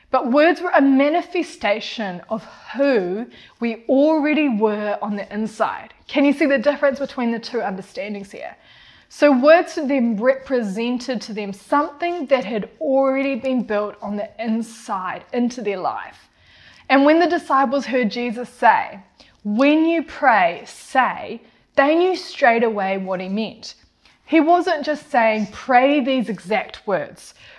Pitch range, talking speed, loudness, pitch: 215-290 Hz, 150 wpm, -19 LUFS, 255 Hz